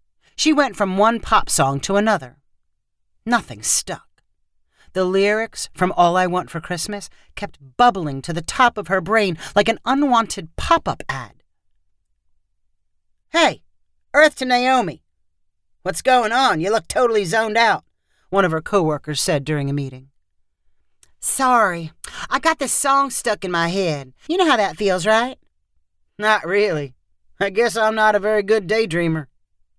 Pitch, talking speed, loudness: 185 Hz, 155 wpm, -19 LUFS